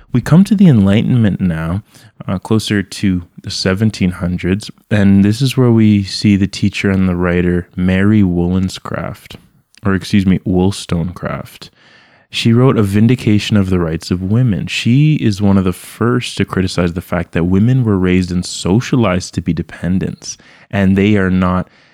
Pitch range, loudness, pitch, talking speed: 90-110 Hz, -14 LUFS, 100 Hz, 165 wpm